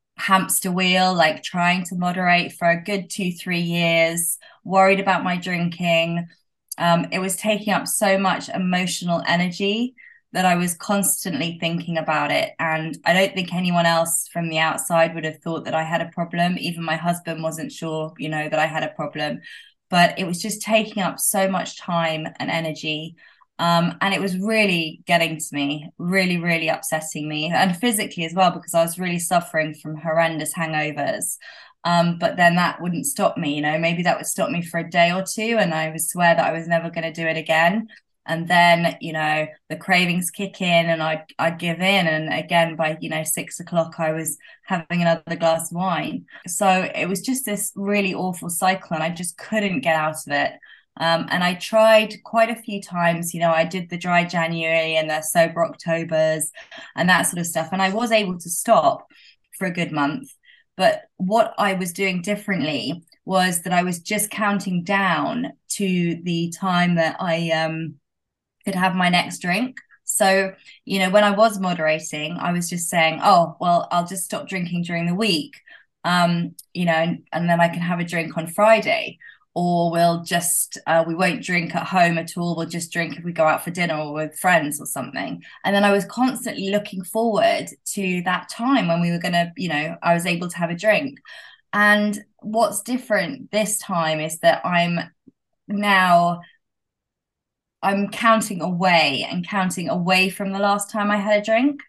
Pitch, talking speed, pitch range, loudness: 175 Hz, 195 wpm, 165-195 Hz, -21 LUFS